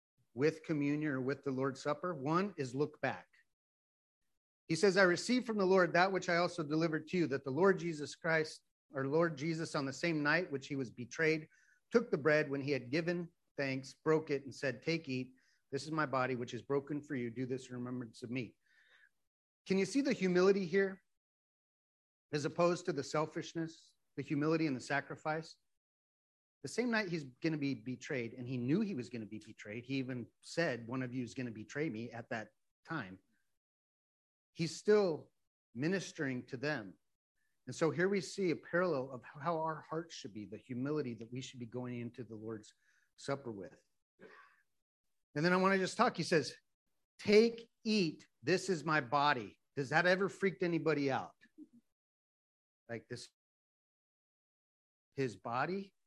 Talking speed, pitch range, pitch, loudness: 185 wpm, 125-170 Hz, 145 Hz, -36 LUFS